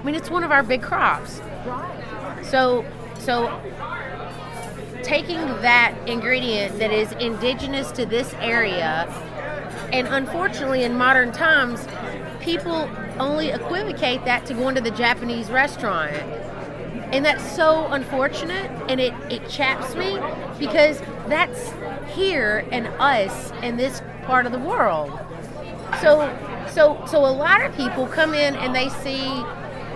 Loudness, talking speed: -21 LUFS, 130 wpm